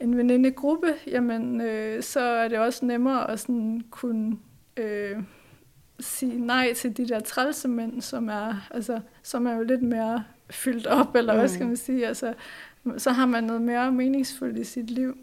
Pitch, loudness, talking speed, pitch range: 240 Hz, -26 LUFS, 175 wpm, 225-255 Hz